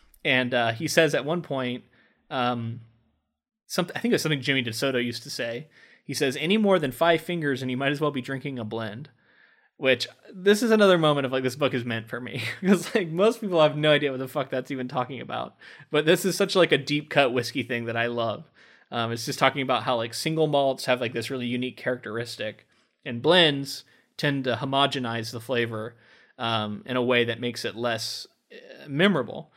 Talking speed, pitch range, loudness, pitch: 215 wpm, 120-150 Hz, -25 LUFS, 130 Hz